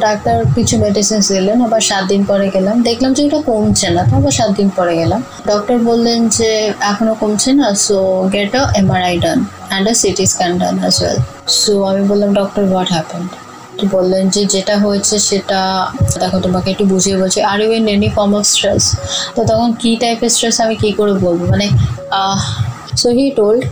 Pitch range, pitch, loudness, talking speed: 190-220 Hz, 205 Hz, -13 LUFS, 170 wpm